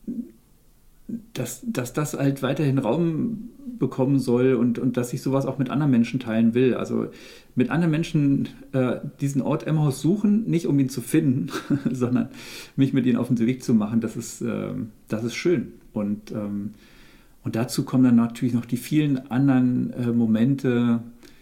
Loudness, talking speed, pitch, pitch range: -23 LUFS, 170 wpm, 130 Hz, 120-145 Hz